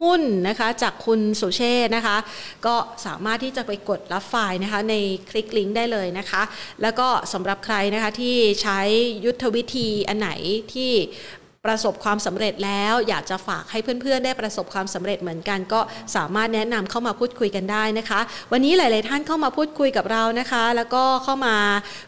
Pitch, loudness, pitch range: 220 Hz, -22 LUFS, 200-240 Hz